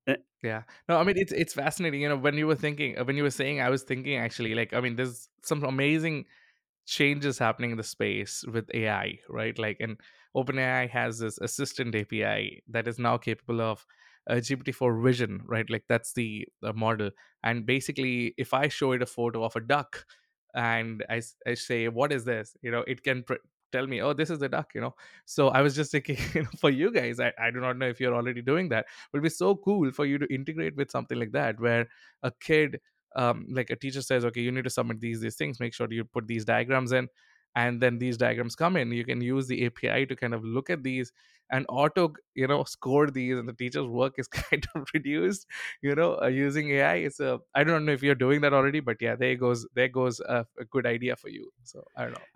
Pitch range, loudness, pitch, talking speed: 115-140 Hz, -28 LUFS, 125 Hz, 235 wpm